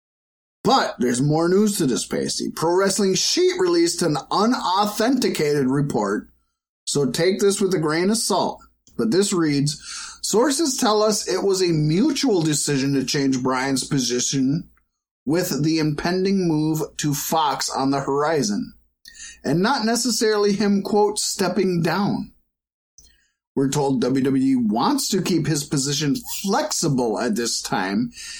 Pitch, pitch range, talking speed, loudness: 175 Hz, 140-215 Hz, 135 wpm, -21 LUFS